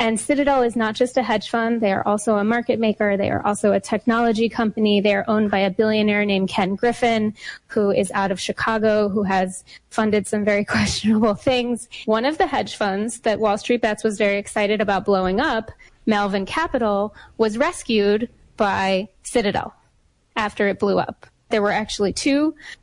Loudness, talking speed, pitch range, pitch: -20 LUFS, 185 wpm, 205-230 Hz, 215 Hz